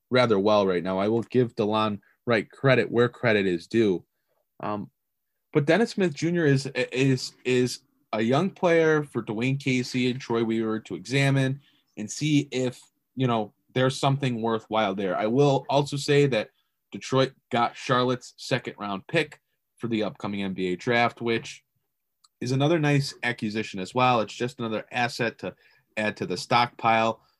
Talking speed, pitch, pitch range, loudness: 160 wpm, 125 Hz, 110-135 Hz, -25 LUFS